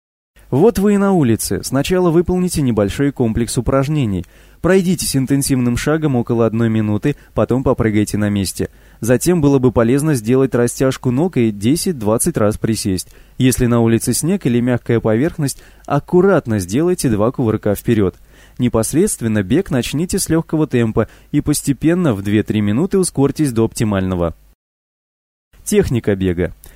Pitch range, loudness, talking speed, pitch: 105-145 Hz, -16 LUFS, 130 wpm, 120 Hz